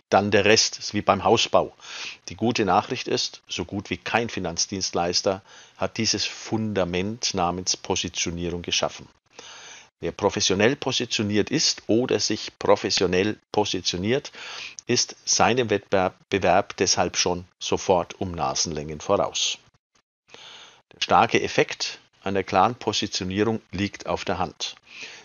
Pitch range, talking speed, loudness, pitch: 90-110 Hz, 115 wpm, -23 LUFS, 100 Hz